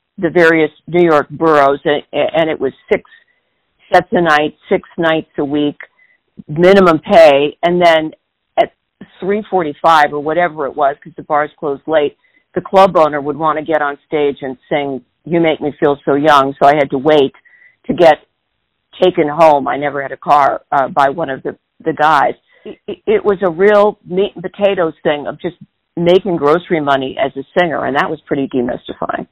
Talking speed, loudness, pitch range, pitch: 190 wpm, -13 LUFS, 145-185 Hz, 160 Hz